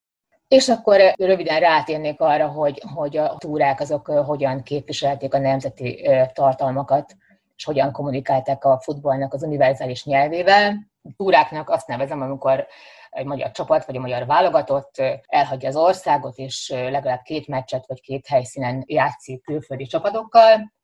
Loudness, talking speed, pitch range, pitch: -20 LUFS, 140 wpm, 135-155 Hz, 140 Hz